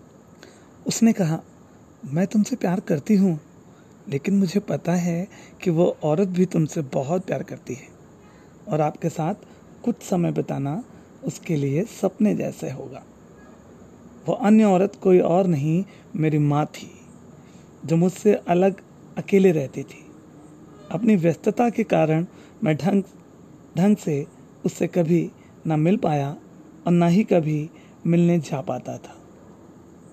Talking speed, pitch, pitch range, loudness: 135 wpm, 175 Hz, 155-195 Hz, -22 LUFS